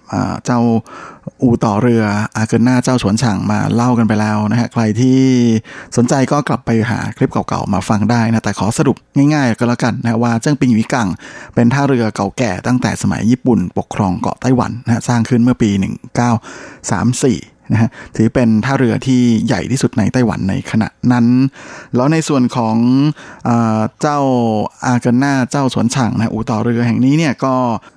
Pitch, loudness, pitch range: 120 Hz, -14 LUFS, 110-130 Hz